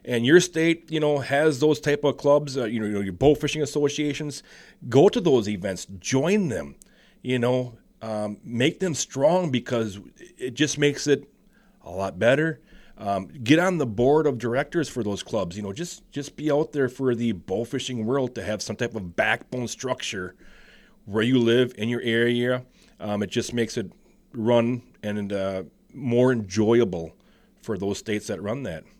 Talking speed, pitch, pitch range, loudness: 180 wpm, 125 Hz, 110-145 Hz, -24 LUFS